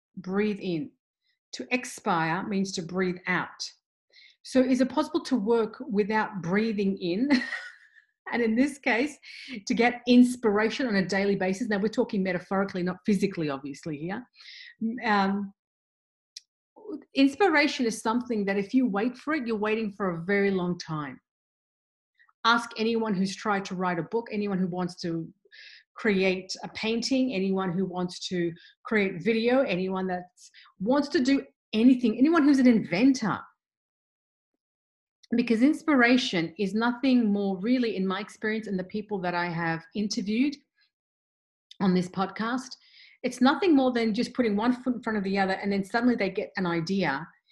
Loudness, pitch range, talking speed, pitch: -27 LUFS, 190-250 Hz, 155 wpm, 215 Hz